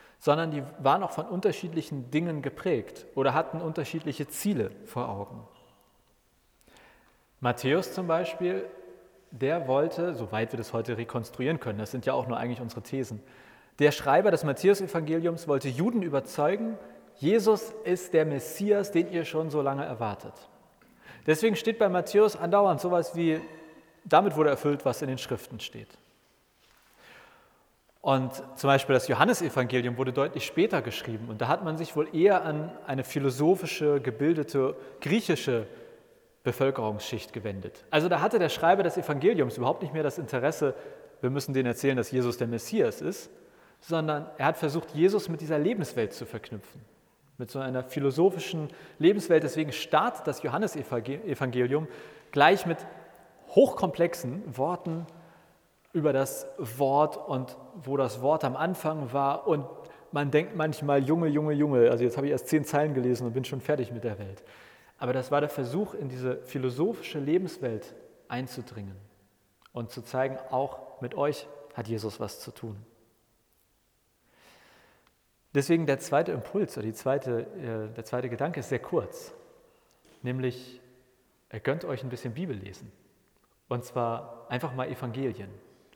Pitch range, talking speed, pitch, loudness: 125-160 Hz, 145 wpm, 140 Hz, -28 LUFS